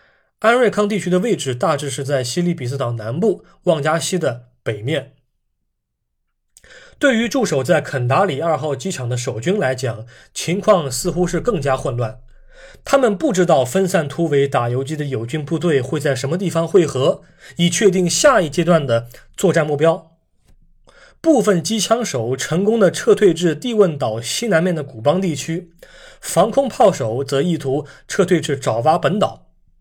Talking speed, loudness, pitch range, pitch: 250 characters per minute, -18 LUFS, 135-195 Hz, 165 Hz